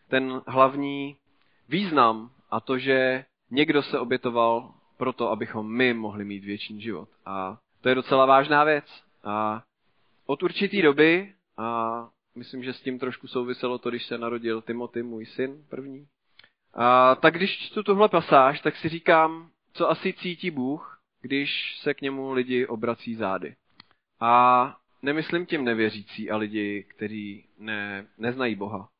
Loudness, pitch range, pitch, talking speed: -25 LUFS, 115-140 Hz, 125 Hz, 145 wpm